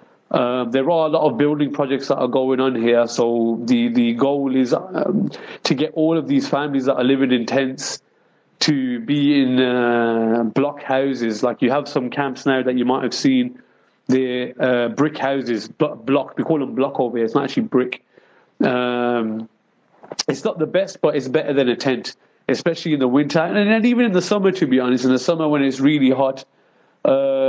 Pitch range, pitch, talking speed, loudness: 125-155 Hz, 135 Hz, 205 wpm, -19 LUFS